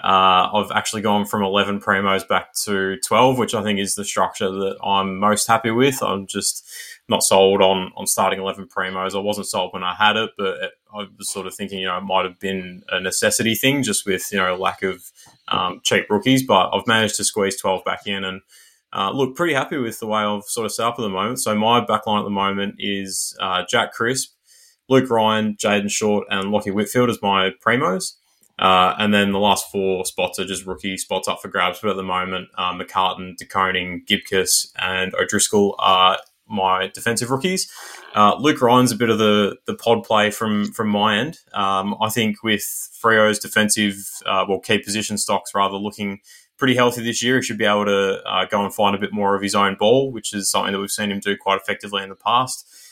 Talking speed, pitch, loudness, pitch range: 220 wpm, 100 Hz, -19 LUFS, 95-110 Hz